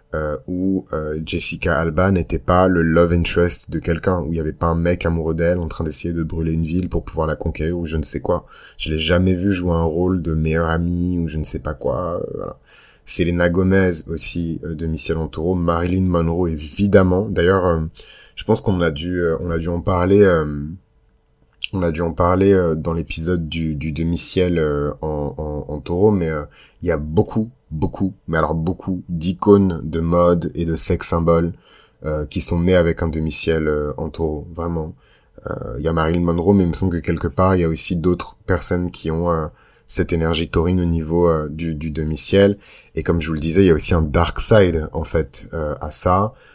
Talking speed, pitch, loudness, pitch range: 210 wpm, 85 Hz, -19 LUFS, 80-90 Hz